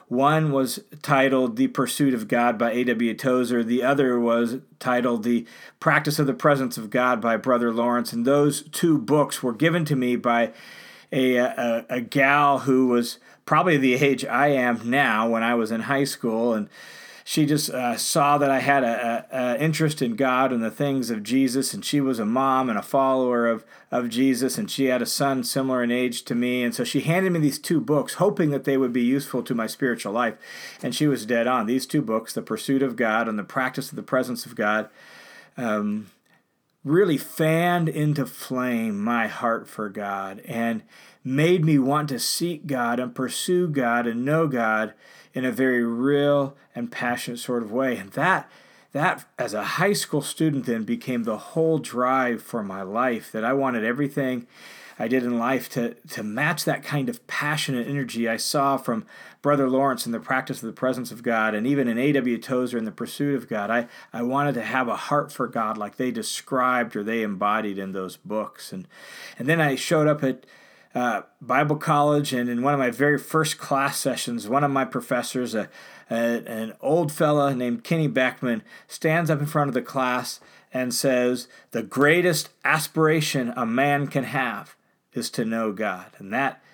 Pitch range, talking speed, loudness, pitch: 120-145 Hz, 195 wpm, -23 LUFS, 130 Hz